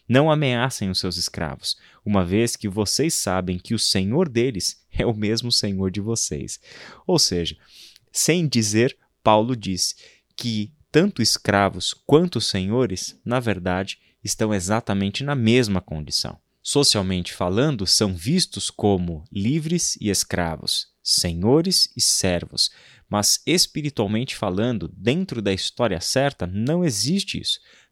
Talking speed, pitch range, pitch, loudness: 125 wpm, 95-125 Hz, 110 Hz, -21 LUFS